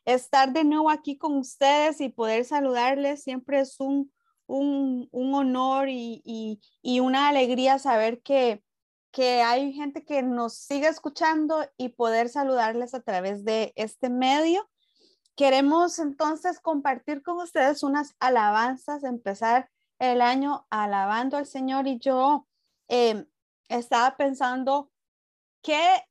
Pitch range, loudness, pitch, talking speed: 245-290 Hz, -25 LUFS, 270 Hz, 130 wpm